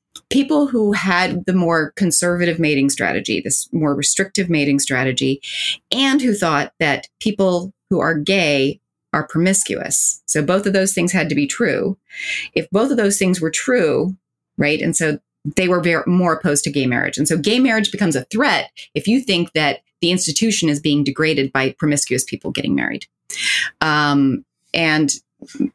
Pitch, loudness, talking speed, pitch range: 165 Hz, -17 LUFS, 170 wpm, 145-195 Hz